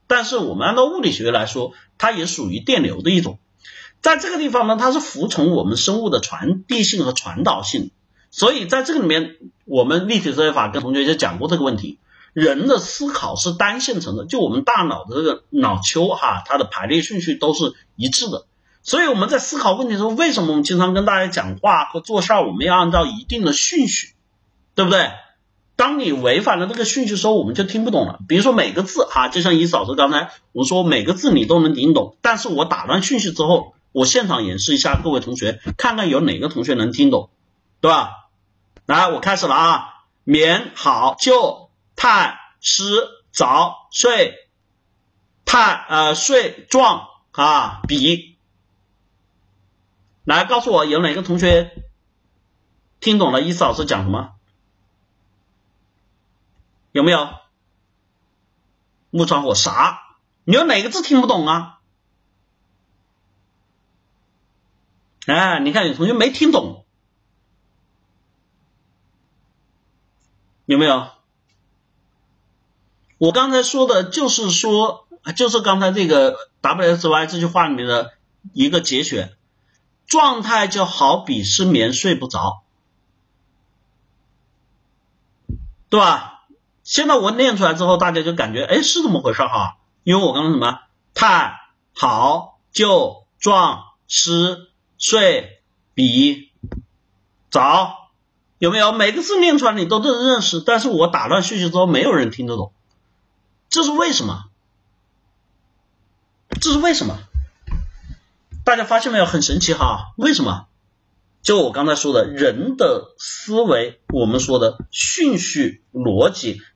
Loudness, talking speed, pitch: -17 LUFS, 220 characters per minute, 175 Hz